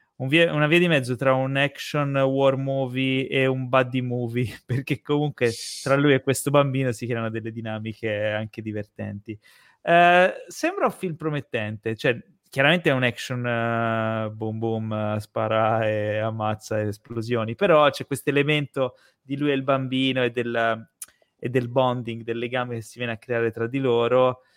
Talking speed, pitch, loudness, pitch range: 165 wpm, 125 Hz, -23 LUFS, 115-135 Hz